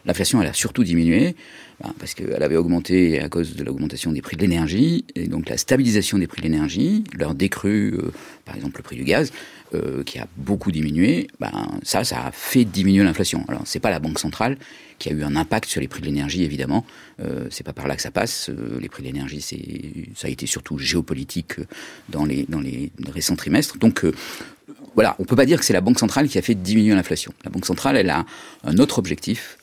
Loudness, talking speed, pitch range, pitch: -21 LUFS, 220 wpm, 80-105 Hz, 95 Hz